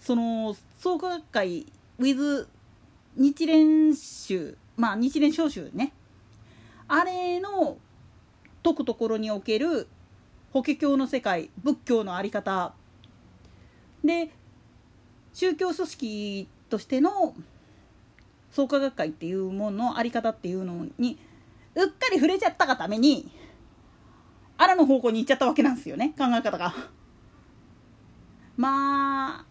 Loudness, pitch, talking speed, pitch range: -26 LUFS, 270 Hz, 230 characters per minute, 220-315 Hz